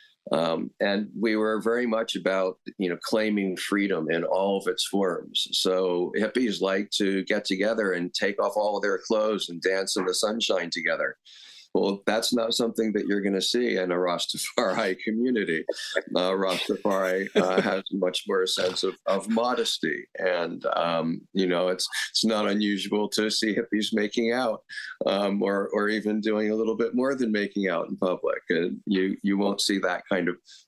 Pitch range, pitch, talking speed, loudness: 95-110 Hz, 100 Hz, 180 wpm, -26 LUFS